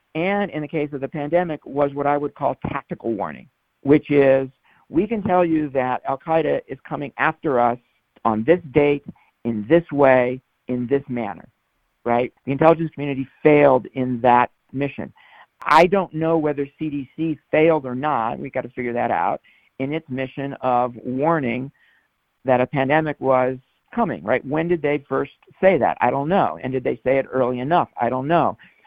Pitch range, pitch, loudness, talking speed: 130-155 Hz, 140 Hz, -21 LUFS, 185 wpm